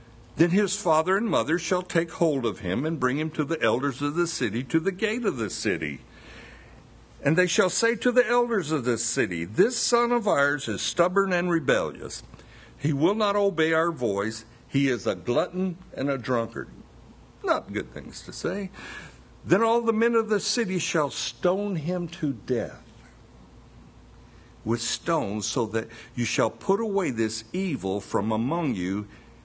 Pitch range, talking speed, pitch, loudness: 120-190 Hz, 175 wpm, 160 Hz, -25 LUFS